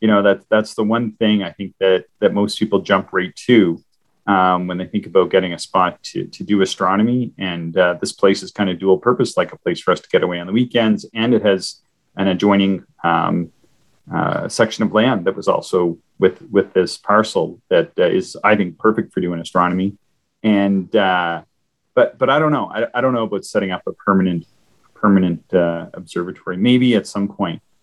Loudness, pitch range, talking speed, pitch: -18 LUFS, 90-110 Hz, 210 wpm, 100 Hz